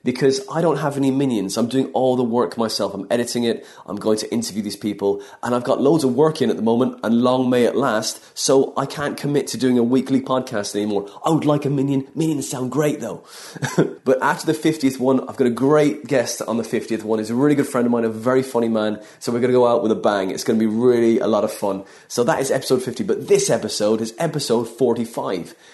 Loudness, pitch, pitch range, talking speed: -20 LUFS, 125 Hz, 115-140 Hz, 250 wpm